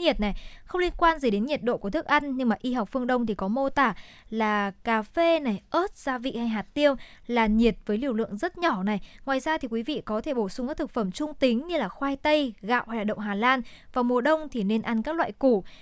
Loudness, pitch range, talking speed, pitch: -26 LUFS, 220-290 Hz, 275 wpm, 245 Hz